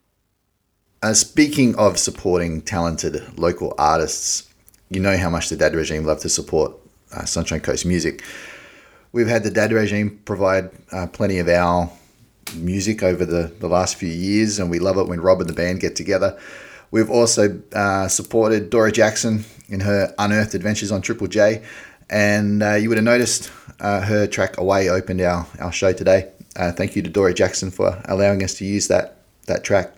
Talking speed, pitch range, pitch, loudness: 180 wpm, 90-105 Hz, 100 Hz, -19 LUFS